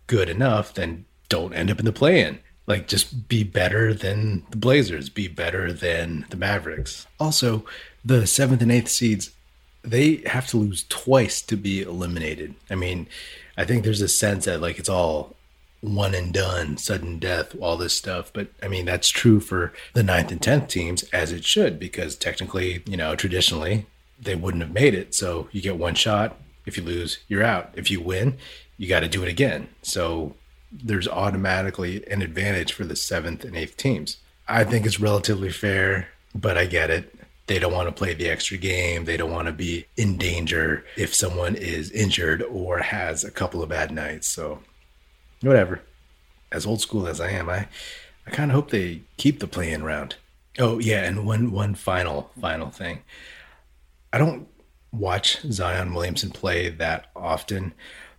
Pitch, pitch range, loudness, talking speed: 95 Hz, 85-105 Hz, -23 LUFS, 180 wpm